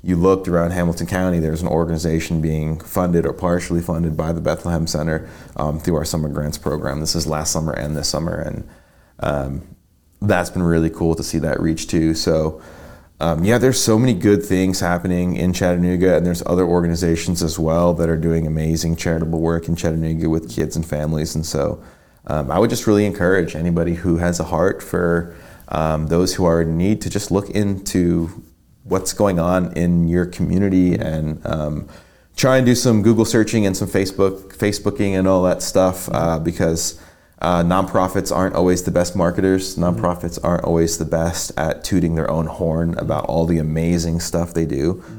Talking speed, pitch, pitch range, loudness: 190 wpm, 85 Hz, 80-90 Hz, -19 LUFS